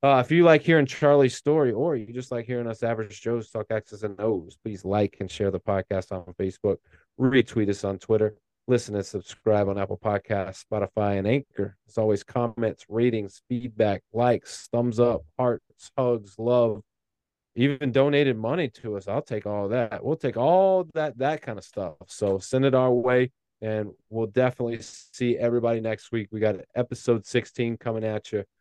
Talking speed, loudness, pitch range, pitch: 180 wpm, -25 LUFS, 105-125 Hz, 115 Hz